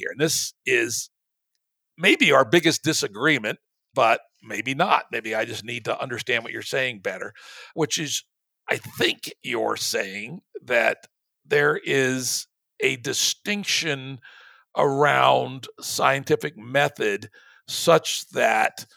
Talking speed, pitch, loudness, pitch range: 115 wpm, 140 Hz, -23 LUFS, 115-185 Hz